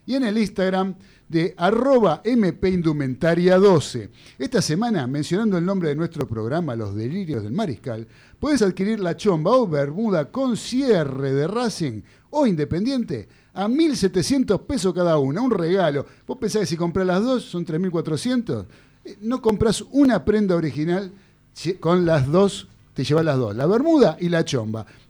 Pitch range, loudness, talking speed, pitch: 145-215 Hz, -21 LUFS, 150 wpm, 175 Hz